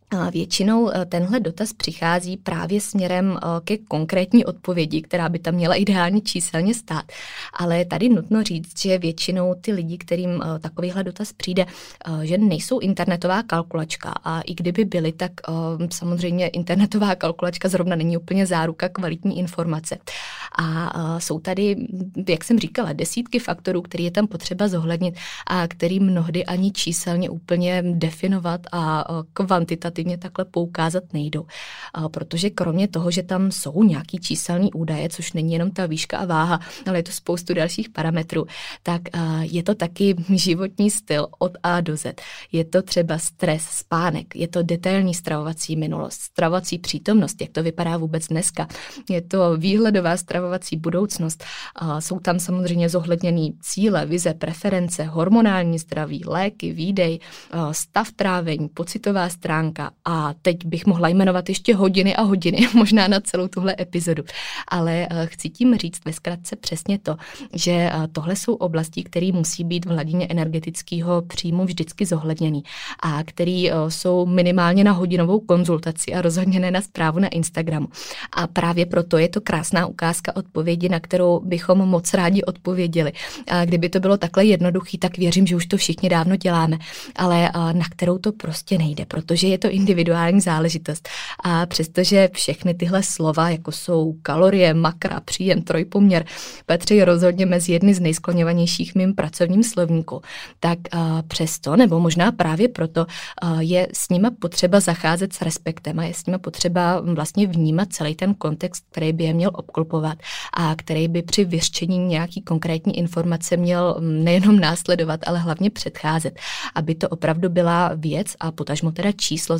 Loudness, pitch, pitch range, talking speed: -21 LUFS, 175 Hz, 165-185 Hz, 150 wpm